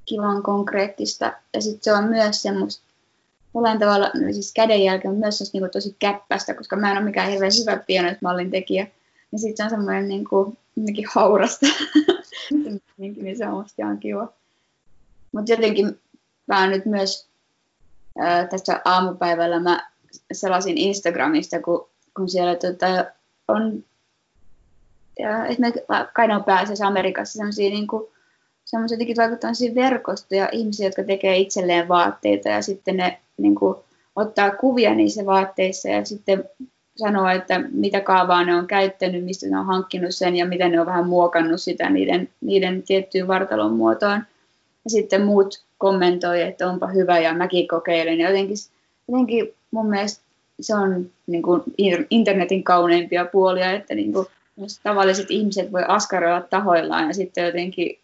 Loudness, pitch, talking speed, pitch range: -21 LUFS, 195 Hz, 150 wpm, 180-210 Hz